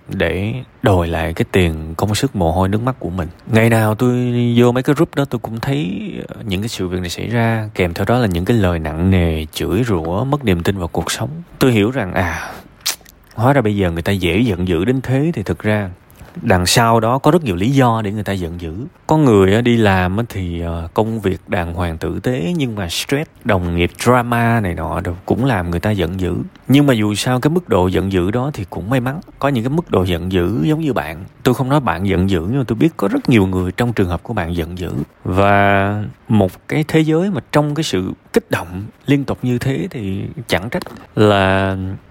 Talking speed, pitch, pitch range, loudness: 240 wpm, 105 Hz, 90-125 Hz, -17 LUFS